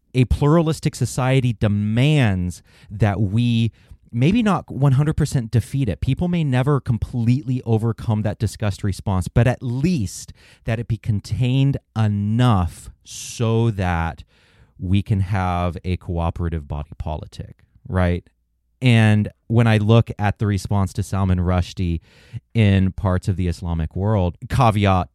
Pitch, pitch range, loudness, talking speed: 110 Hz, 95-125 Hz, -20 LUFS, 130 wpm